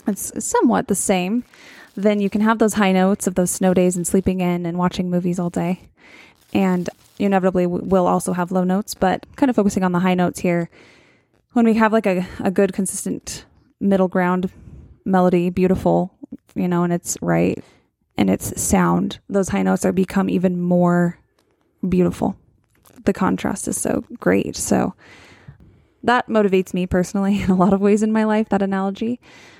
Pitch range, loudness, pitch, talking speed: 180-205 Hz, -19 LUFS, 190 Hz, 175 wpm